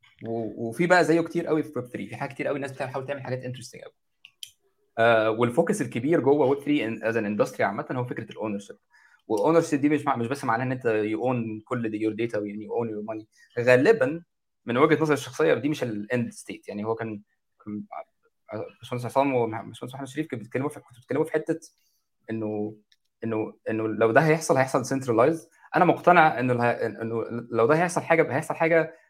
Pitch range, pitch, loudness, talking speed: 115-150 Hz, 125 Hz, -25 LUFS, 190 wpm